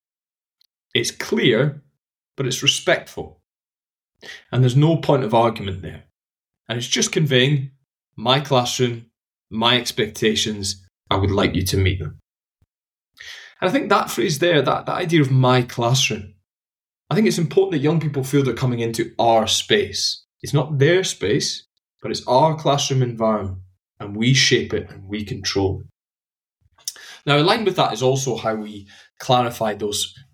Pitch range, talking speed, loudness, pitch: 105-140 Hz, 155 wpm, -19 LUFS, 125 Hz